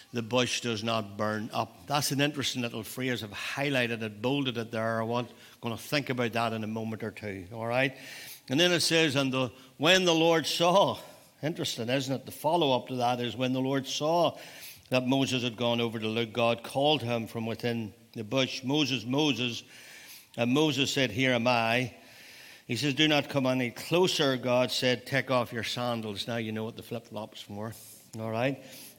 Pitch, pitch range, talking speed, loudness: 125 Hz, 115-135 Hz, 205 wpm, -29 LUFS